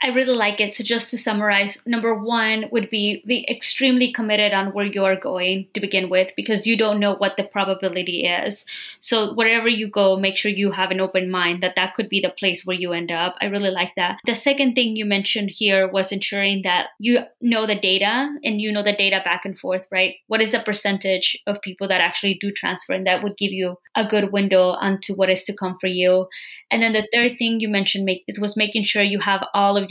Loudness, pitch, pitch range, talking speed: -20 LUFS, 200 Hz, 190-220 Hz, 235 wpm